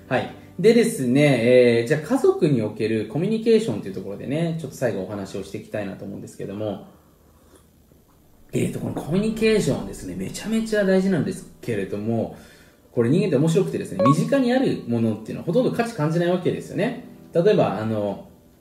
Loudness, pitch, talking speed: -22 LUFS, 125 Hz, 450 characters per minute